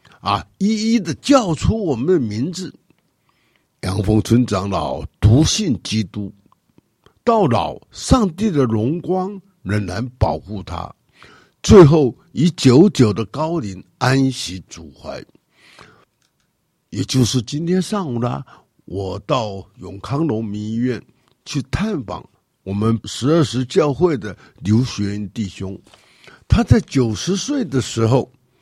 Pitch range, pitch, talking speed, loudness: 105-155 Hz, 125 Hz, 175 characters per minute, -18 LUFS